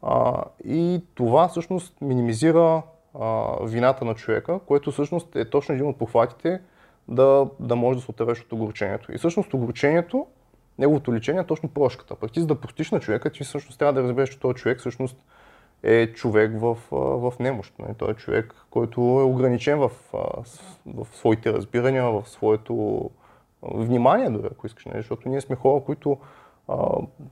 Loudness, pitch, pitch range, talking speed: -23 LUFS, 130 Hz, 120-145 Hz, 160 wpm